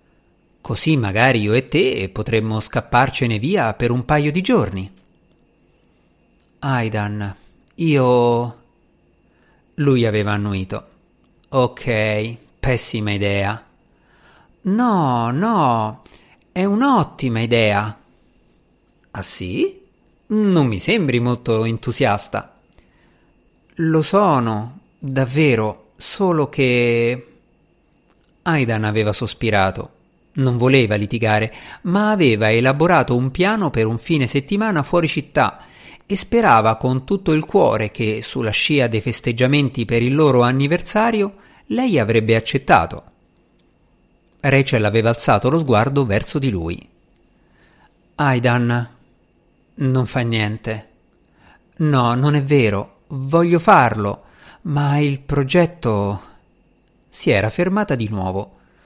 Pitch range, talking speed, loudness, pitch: 110-150 Hz, 100 wpm, -18 LUFS, 125 Hz